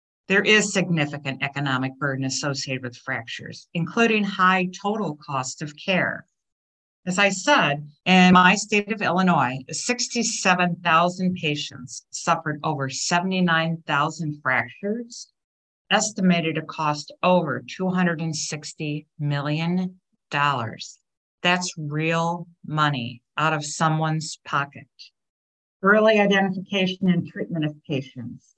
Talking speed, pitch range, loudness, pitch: 100 wpm, 145-185 Hz, -22 LUFS, 160 Hz